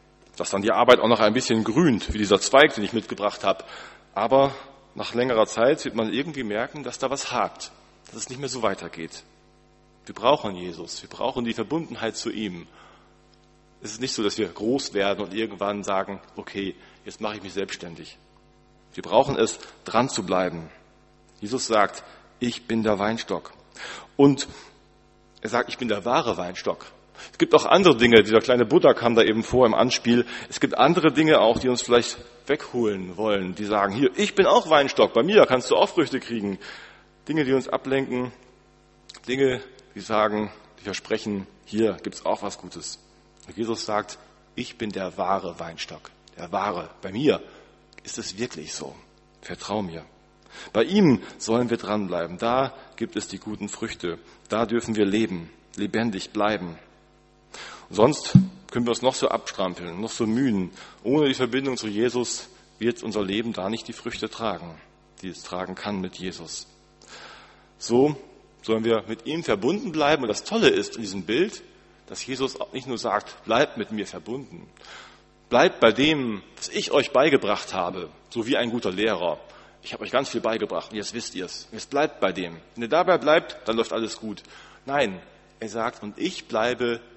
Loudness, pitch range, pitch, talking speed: -24 LUFS, 100-125 Hz, 115 Hz, 180 wpm